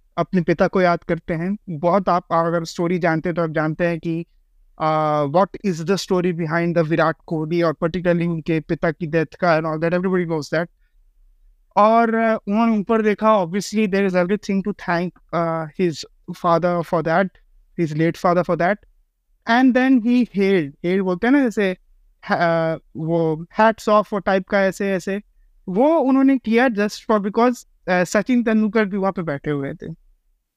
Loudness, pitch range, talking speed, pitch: -20 LUFS, 165-205 Hz, 160 wpm, 180 Hz